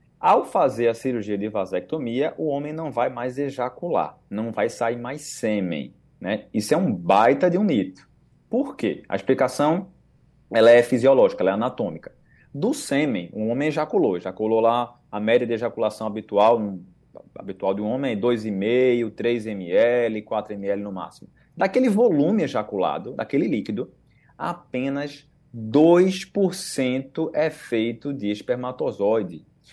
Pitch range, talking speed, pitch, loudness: 110-145 Hz, 145 wpm, 120 Hz, -23 LUFS